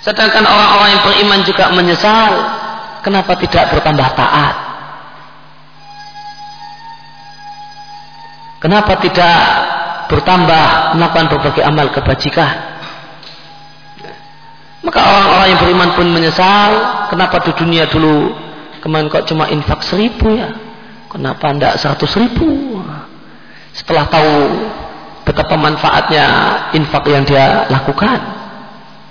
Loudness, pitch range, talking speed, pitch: -10 LUFS, 160-220 Hz, 95 wpm, 185 Hz